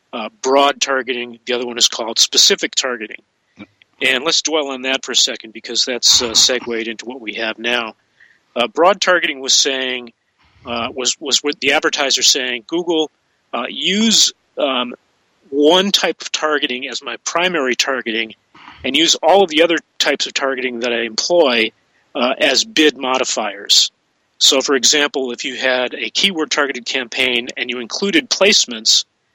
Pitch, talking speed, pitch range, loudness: 130 Hz, 165 wpm, 120-155 Hz, -15 LUFS